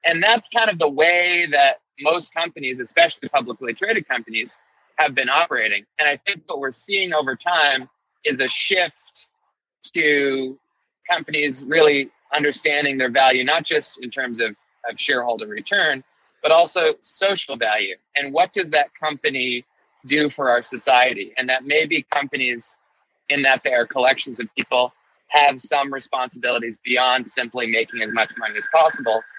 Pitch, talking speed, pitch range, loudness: 145 Hz, 155 wpm, 125-165 Hz, -19 LUFS